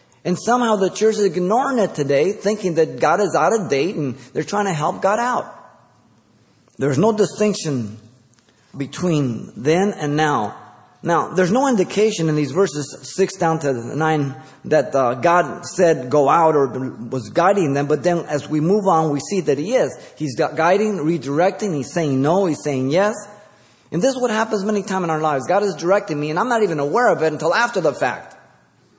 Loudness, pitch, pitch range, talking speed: -19 LUFS, 160 Hz, 140-200 Hz, 195 wpm